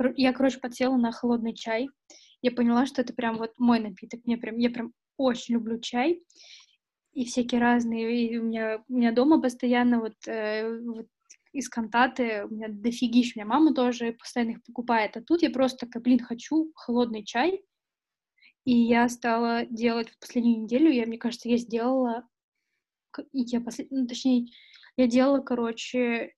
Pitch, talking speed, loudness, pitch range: 240 Hz, 170 wpm, -26 LUFS, 230-255 Hz